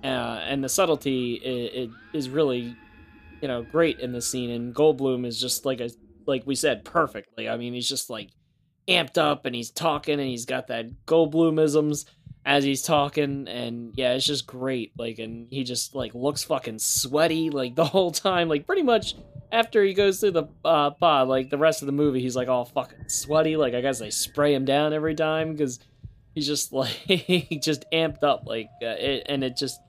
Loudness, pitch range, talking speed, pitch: -25 LUFS, 125-155 Hz, 210 wpm, 140 Hz